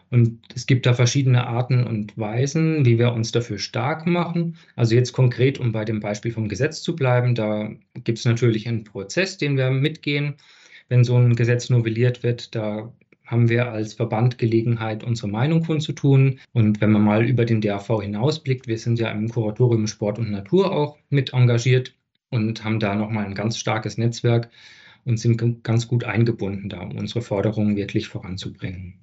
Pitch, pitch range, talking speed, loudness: 120 Hz, 110-130 Hz, 180 wpm, -21 LUFS